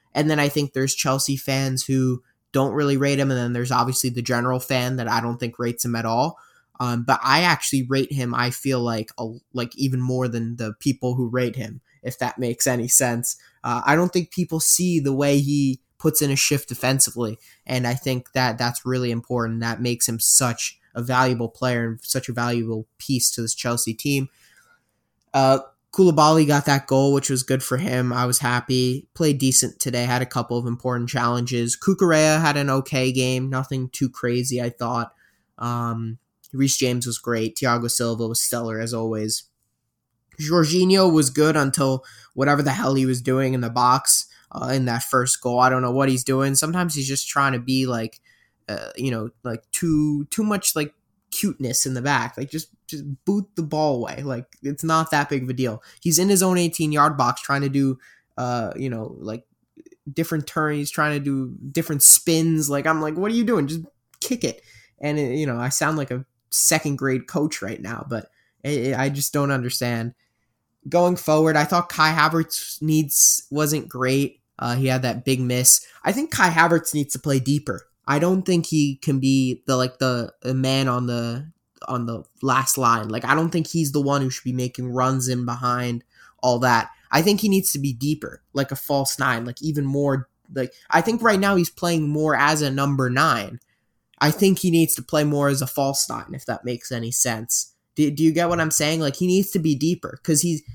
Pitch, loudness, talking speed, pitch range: 130 Hz, -21 LUFS, 210 wpm, 120-150 Hz